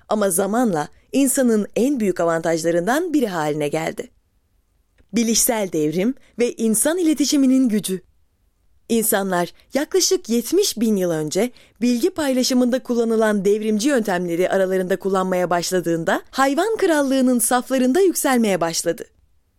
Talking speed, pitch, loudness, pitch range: 105 wpm, 215 Hz, -19 LUFS, 175-260 Hz